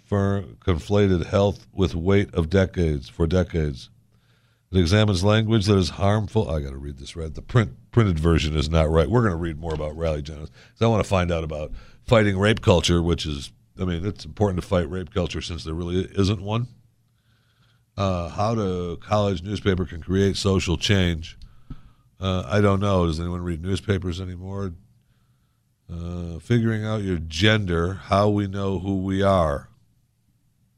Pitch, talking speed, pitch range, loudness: 95 Hz, 175 wpm, 85-110 Hz, -23 LUFS